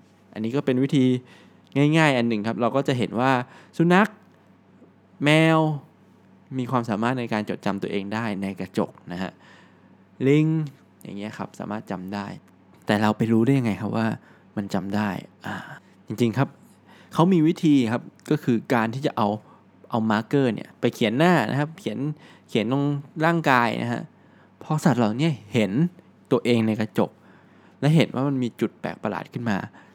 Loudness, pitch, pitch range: -23 LUFS, 125 Hz, 110-145 Hz